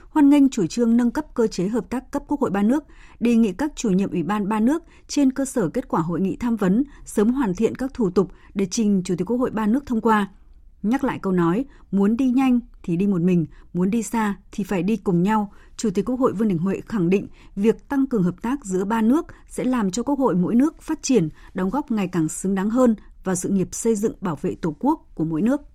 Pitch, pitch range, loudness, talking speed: 220 Hz, 190-250 Hz, -22 LUFS, 265 wpm